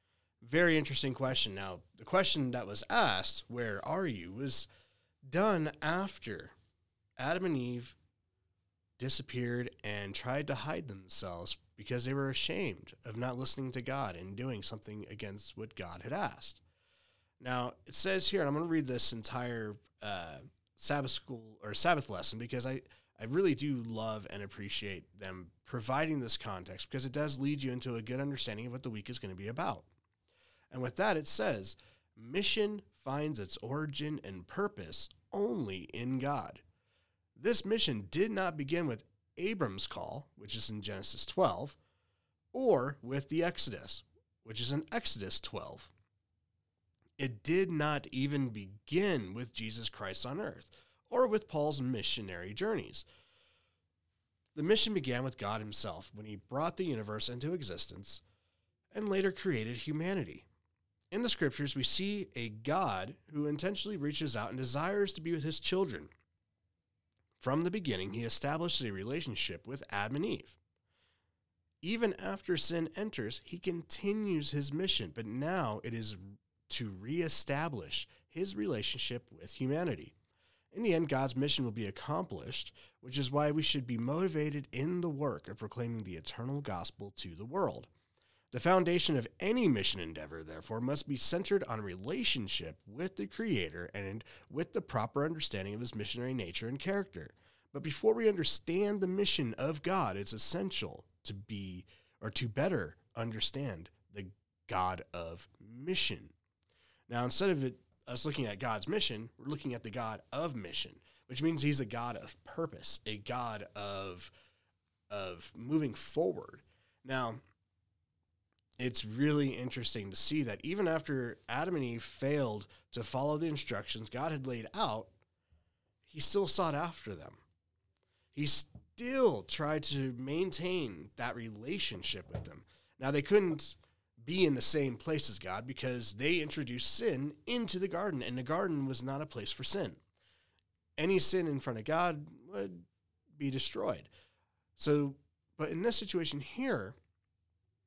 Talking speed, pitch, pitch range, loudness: 155 wpm, 125 Hz, 100-150 Hz, -35 LUFS